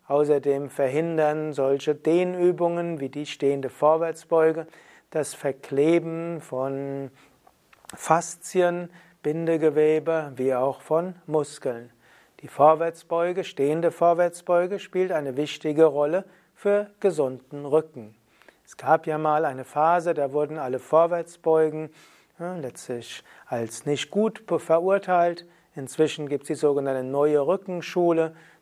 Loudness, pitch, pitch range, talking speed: -24 LUFS, 155 Hz, 145-170 Hz, 105 wpm